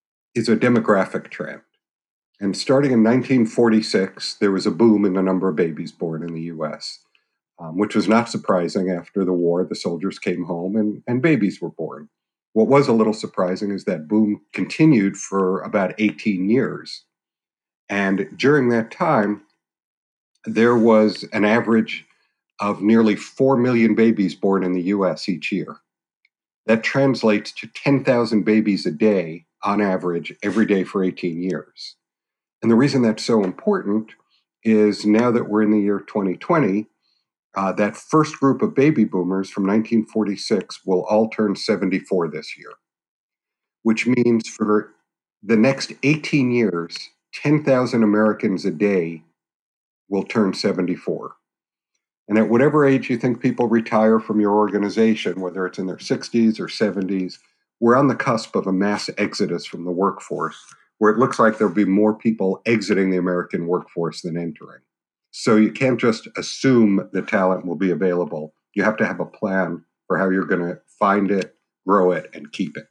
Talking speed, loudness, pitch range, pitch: 165 wpm, -20 LUFS, 95-115 Hz, 105 Hz